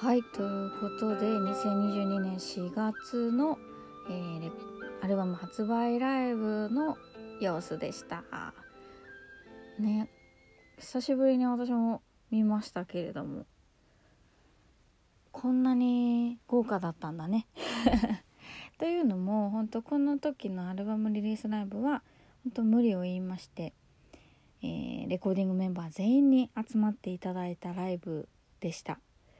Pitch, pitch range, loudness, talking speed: 220 Hz, 190-245 Hz, -32 LUFS, 245 characters per minute